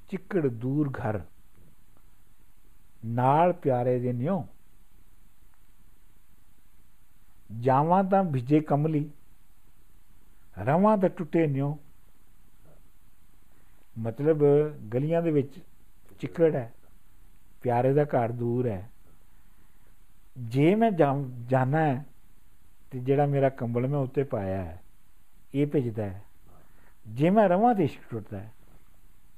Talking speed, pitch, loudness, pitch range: 95 wpm, 120 Hz, -26 LUFS, 95-145 Hz